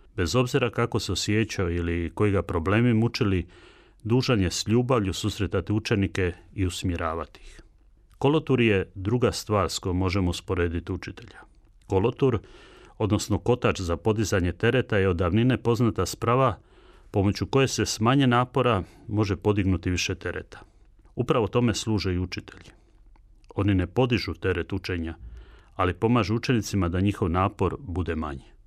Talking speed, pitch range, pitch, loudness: 140 wpm, 90-115 Hz, 100 Hz, -25 LUFS